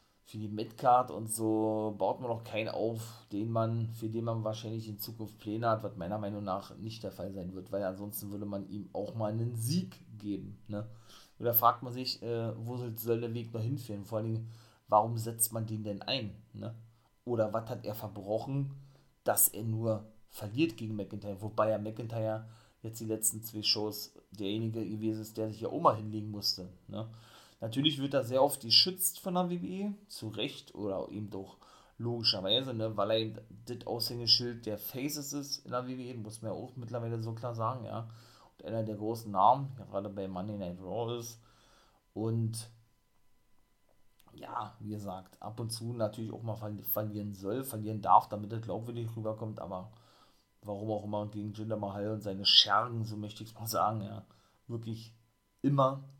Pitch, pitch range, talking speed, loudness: 110 Hz, 105-115 Hz, 185 wpm, -34 LUFS